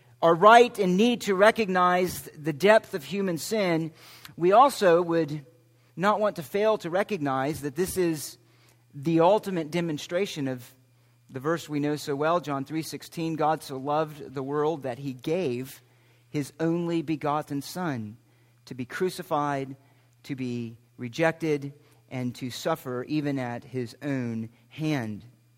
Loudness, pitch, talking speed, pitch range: -26 LUFS, 150 Hz, 145 wpm, 125-170 Hz